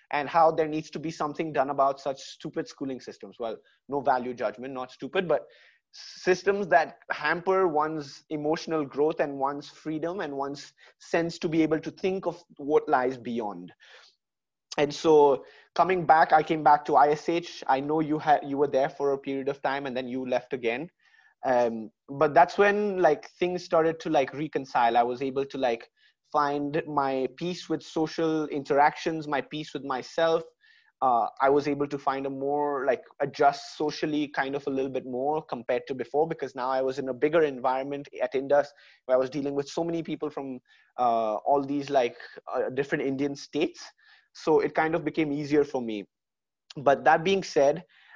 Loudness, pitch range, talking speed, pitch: -27 LUFS, 135-165 Hz, 190 wpm, 145 Hz